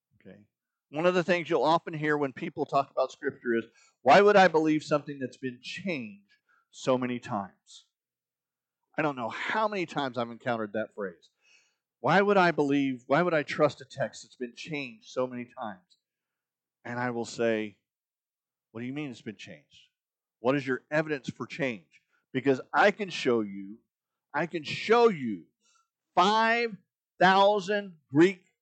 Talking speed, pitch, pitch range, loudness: 165 wpm, 140 Hz, 120-180 Hz, -28 LUFS